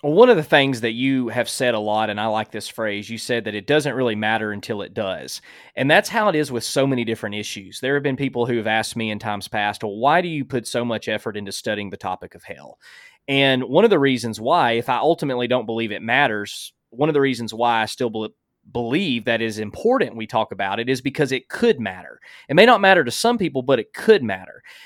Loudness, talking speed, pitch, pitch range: -20 LUFS, 255 wpm, 120 Hz, 110-145 Hz